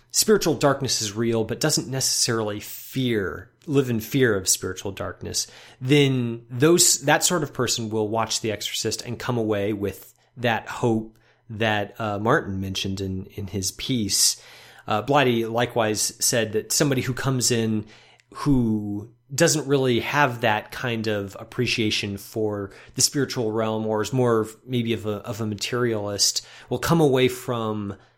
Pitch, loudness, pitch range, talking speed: 115 Hz, -23 LUFS, 110-130 Hz, 155 wpm